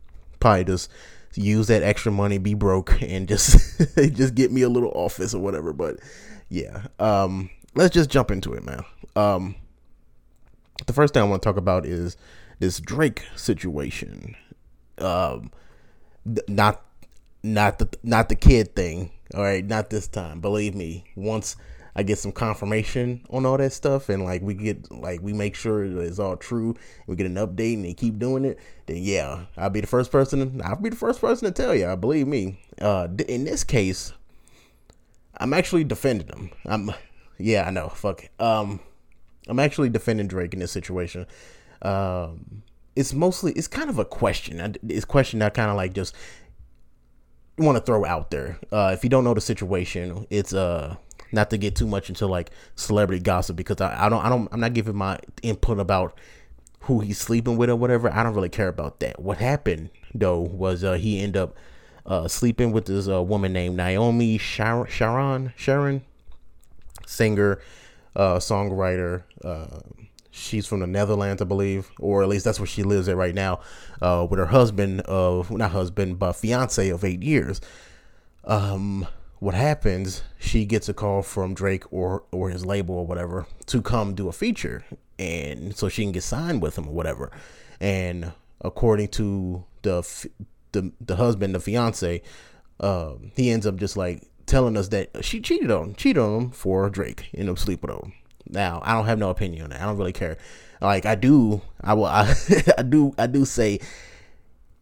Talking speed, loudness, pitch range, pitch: 185 wpm, -24 LUFS, 90-115 Hz, 100 Hz